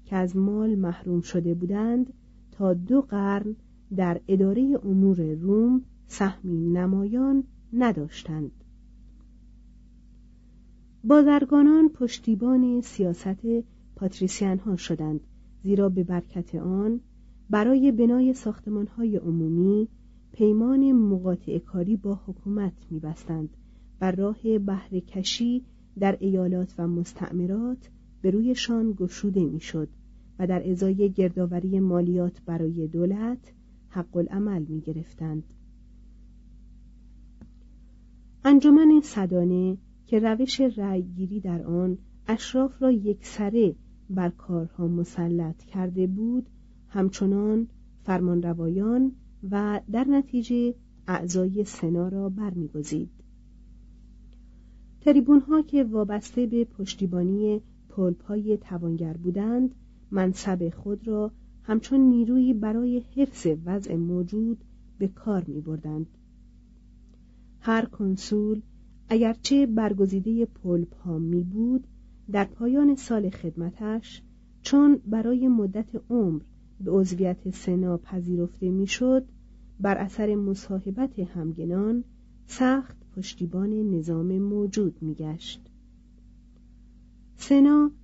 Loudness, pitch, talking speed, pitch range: -25 LUFS, 200 Hz, 95 wpm, 180-230 Hz